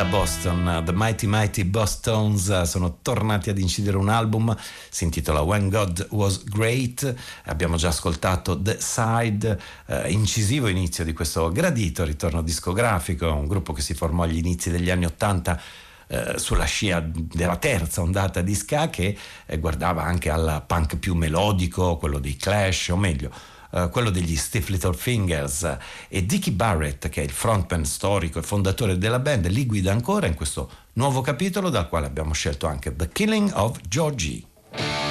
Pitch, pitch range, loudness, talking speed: 90 Hz, 85-105 Hz, -24 LUFS, 160 wpm